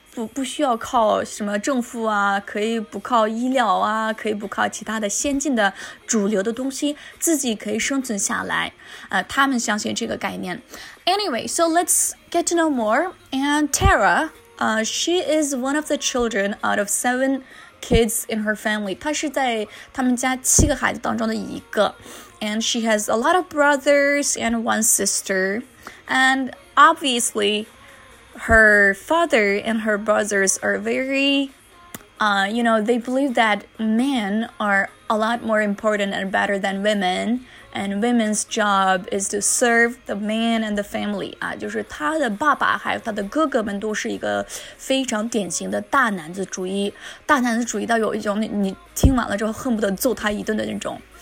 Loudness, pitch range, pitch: -20 LUFS, 210-270 Hz, 225 Hz